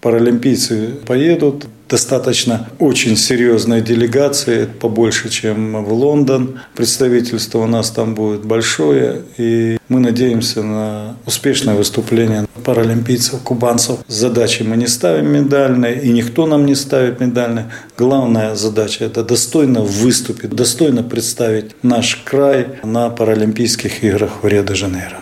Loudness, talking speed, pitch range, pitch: -14 LUFS, 115 wpm, 110-125 Hz, 115 Hz